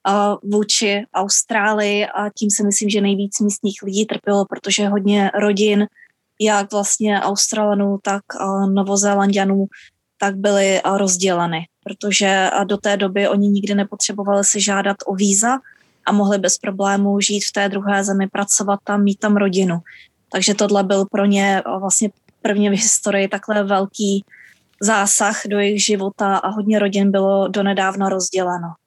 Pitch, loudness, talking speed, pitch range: 200 Hz, -17 LUFS, 145 wpm, 195-205 Hz